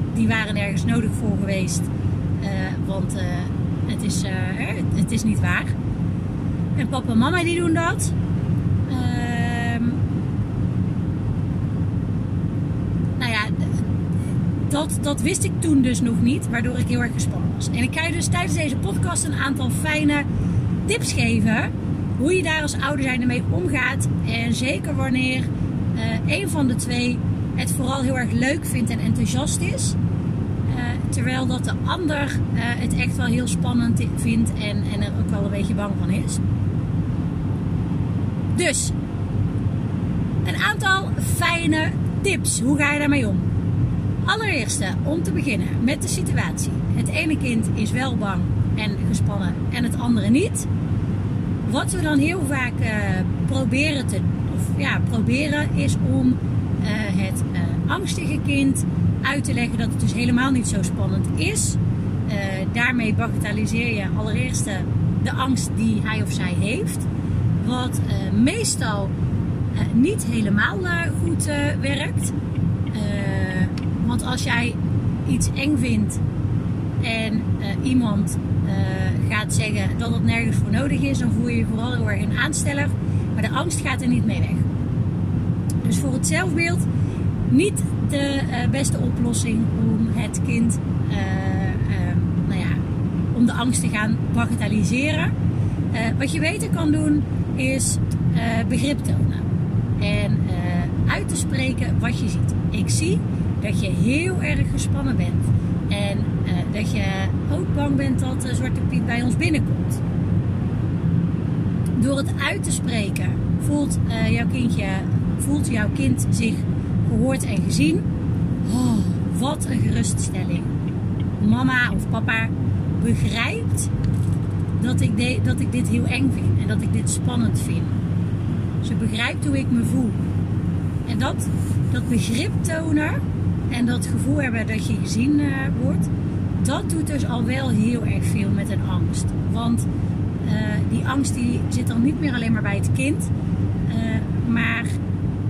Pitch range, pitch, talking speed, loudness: 95-115 Hz, 105 Hz, 150 wpm, -22 LUFS